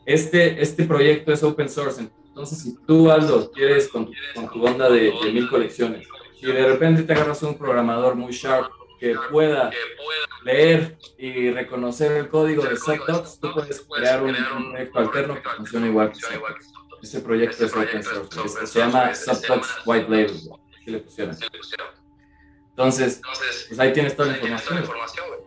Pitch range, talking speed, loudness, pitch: 120-155 Hz, 160 wpm, -21 LUFS, 130 Hz